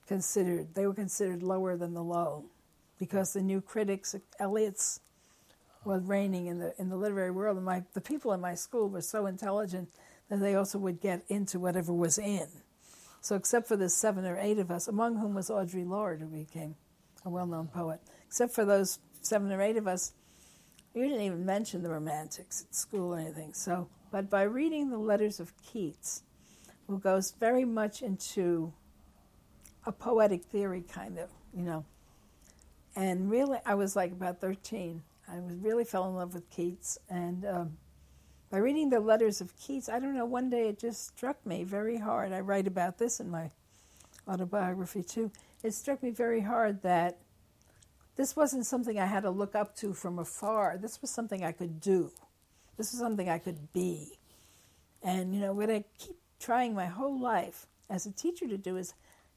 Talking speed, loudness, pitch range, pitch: 185 wpm, -33 LUFS, 175-215 Hz, 190 Hz